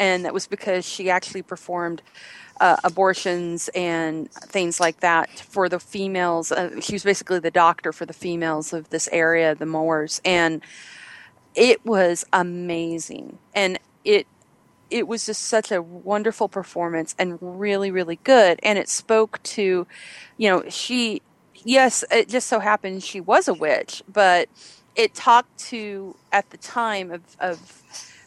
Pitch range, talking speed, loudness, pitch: 170-210 Hz, 155 wpm, -21 LUFS, 185 Hz